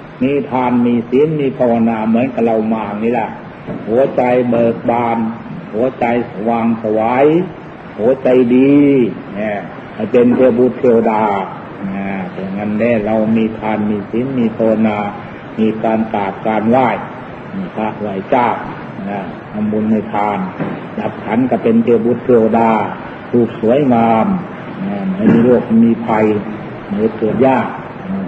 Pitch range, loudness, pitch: 110-125 Hz, -14 LUFS, 115 Hz